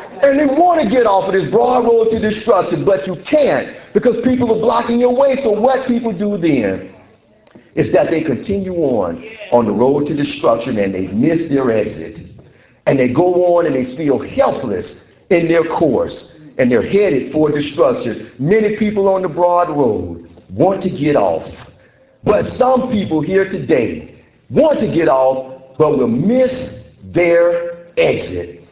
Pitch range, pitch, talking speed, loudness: 150-235 Hz, 190 Hz, 170 wpm, -15 LUFS